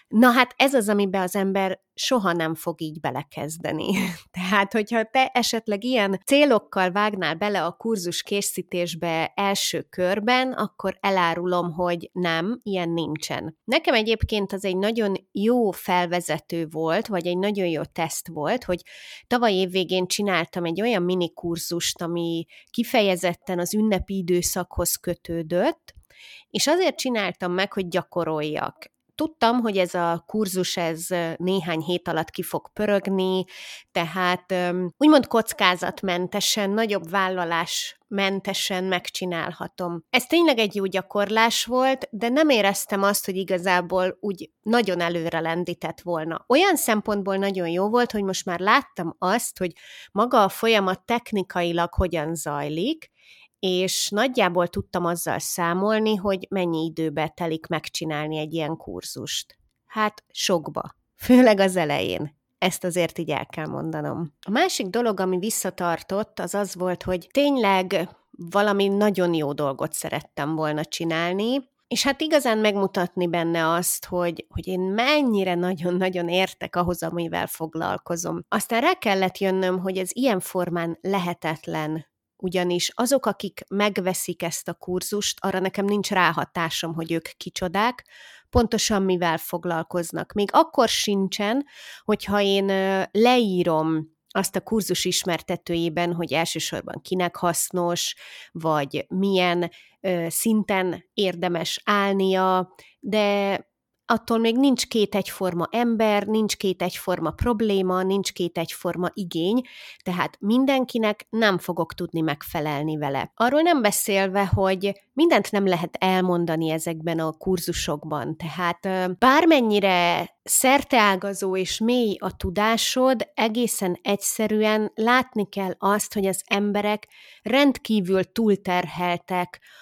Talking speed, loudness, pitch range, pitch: 125 wpm, -23 LUFS, 175-215 Hz, 190 Hz